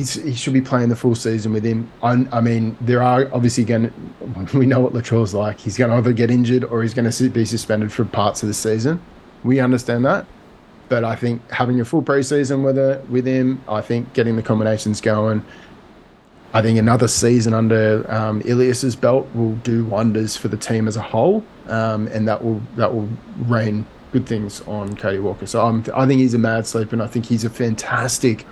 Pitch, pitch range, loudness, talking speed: 115 Hz, 110-125 Hz, -19 LUFS, 220 wpm